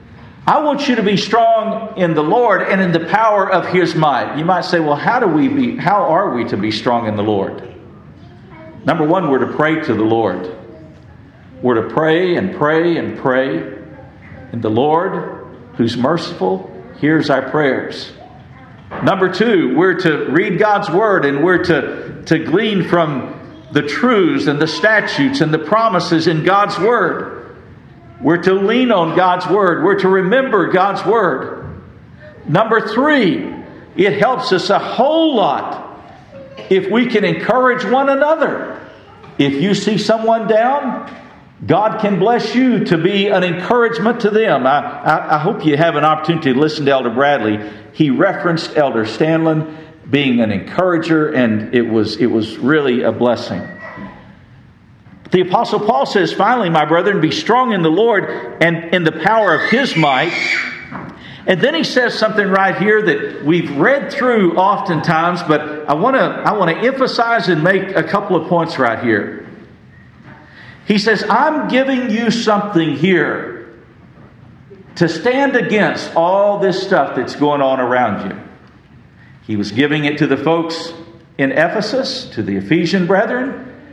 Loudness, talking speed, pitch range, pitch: -14 LUFS, 160 wpm, 145-210 Hz, 175 Hz